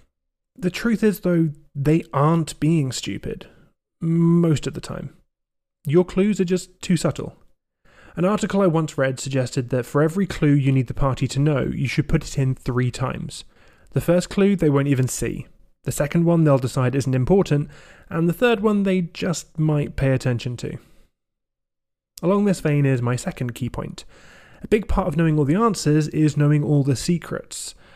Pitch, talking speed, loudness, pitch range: 155 Hz, 185 wpm, -21 LUFS, 135-180 Hz